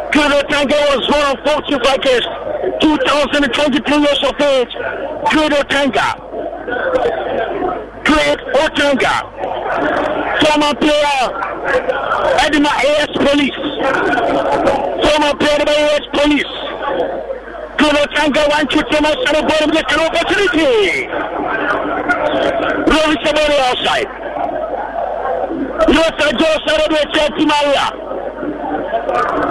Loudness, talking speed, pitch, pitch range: -14 LUFS, 70 wpm, 295 Hz, 285-310 Hz